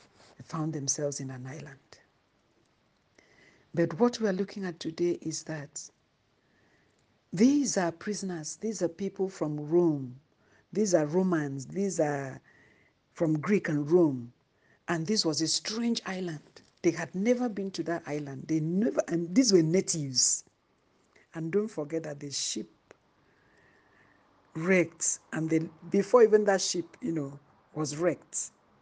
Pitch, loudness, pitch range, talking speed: 165 Hz, -29 LUFS, 150-190 Hz, 140 wpm